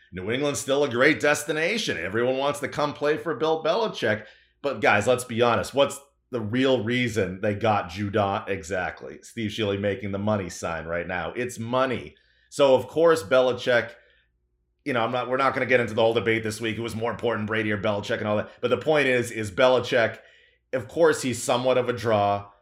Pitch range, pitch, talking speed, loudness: 105-130 Hz, 120 Hz, 205 wpm, -24 LUFS